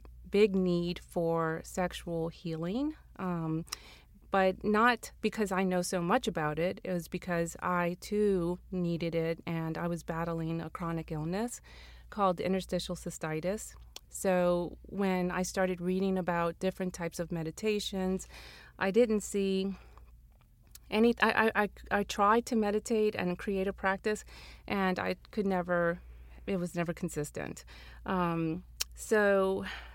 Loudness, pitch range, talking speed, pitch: -32 LUFS, 165-195 Hz, 130 wpm, 180 Hz